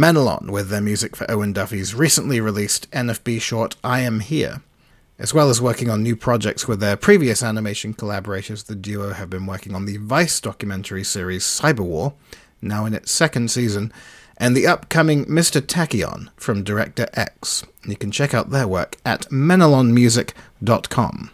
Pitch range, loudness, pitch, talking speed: 105-125 Hz, -19 LUFS, 115 Hz, 165 wpm